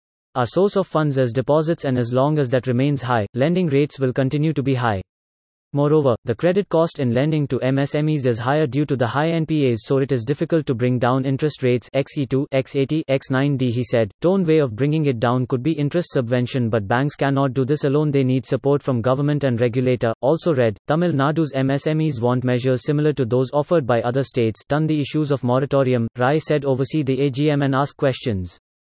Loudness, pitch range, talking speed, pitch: -20 LUFS, 125-150 Hz, 205 wpm, 135 Hz